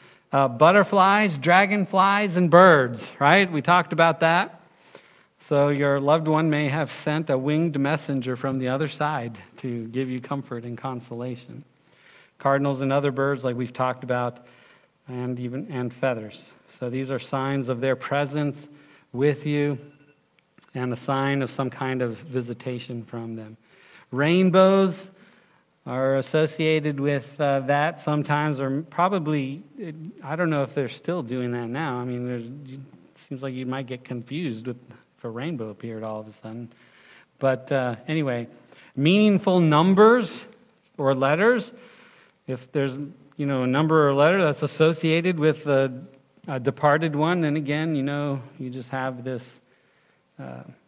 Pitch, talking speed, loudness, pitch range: 140 Hz, 150 wpm, -23 LUFS, 130-155 Hz